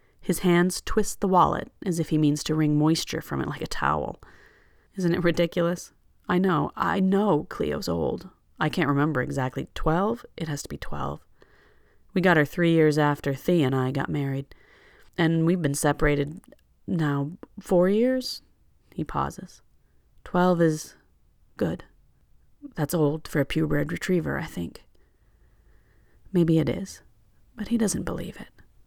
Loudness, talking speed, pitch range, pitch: -25 LUFS, 155 wpm, 145-185 Hz, 165 Hz